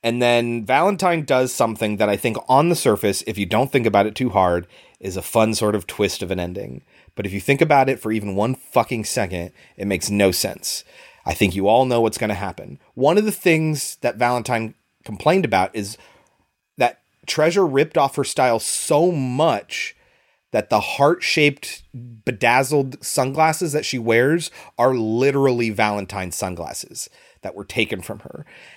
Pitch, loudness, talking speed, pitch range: 115 Hz, -20 LUFS, 180 wpm, 100-135 Hz